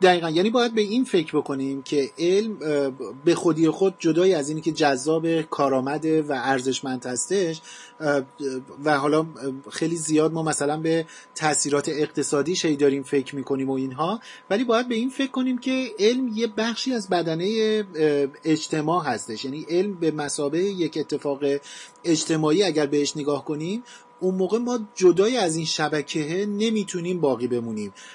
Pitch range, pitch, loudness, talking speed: 145-195 Hz, 160 Hz, -24 LUFS, 150 wpm